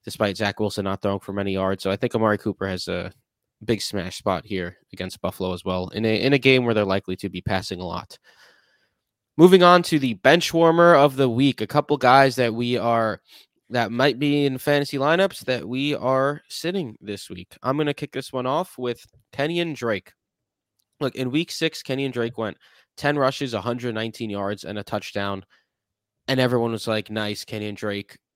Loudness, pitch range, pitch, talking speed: -22 LUFS, 100-135 Hz, 115 Hz, 200 wpm